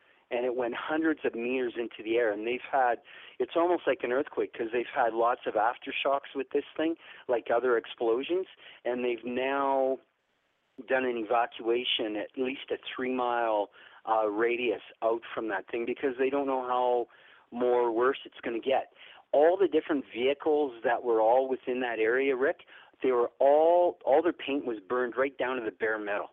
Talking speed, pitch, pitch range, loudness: 185 wpm, 130 Hz, 120-155 Hz, -29 LUFS